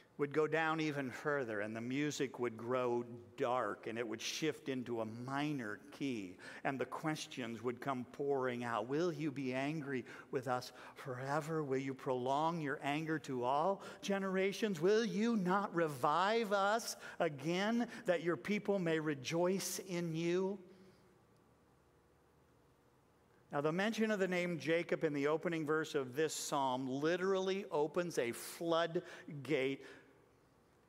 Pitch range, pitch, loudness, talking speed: 130-180 Hz, 155 Hz, -38 LUFS, 140 wpm